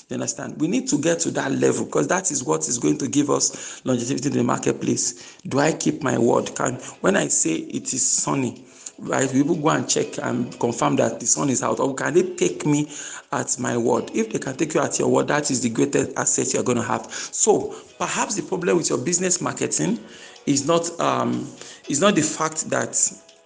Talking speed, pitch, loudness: 230 wpm, 150 Hz, -22 LUFS